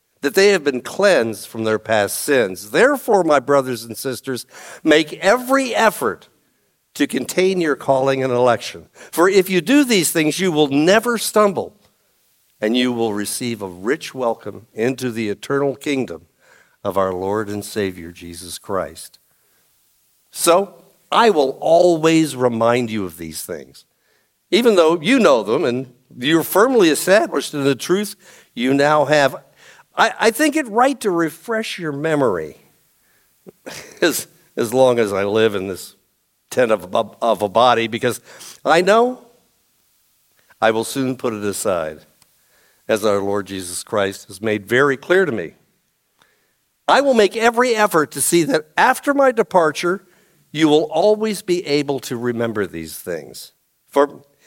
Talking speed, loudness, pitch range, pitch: 150 wpm, -18 LUFS, 115-180 Hz, 140 Hz